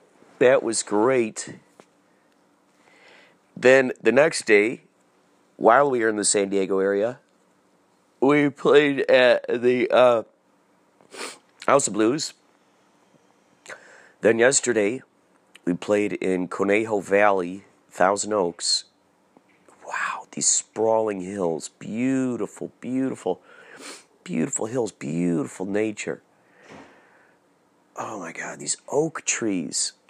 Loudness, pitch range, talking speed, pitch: -22 LUFS, 95-125 Hz, 95 wpm, 105 Hz